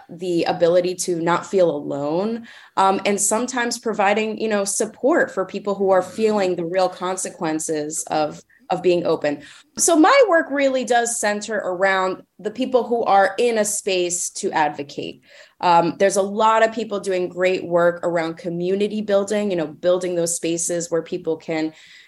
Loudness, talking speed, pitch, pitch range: -20 LUFS, 165 wpm, 185 Hz, 170-210 Hz